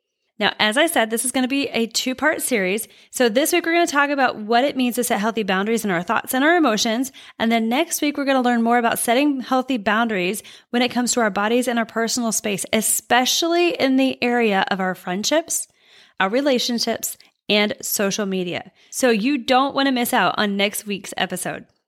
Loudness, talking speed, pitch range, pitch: -20 LUFS, 220 wpm, 215-265 Hz, 240 Hz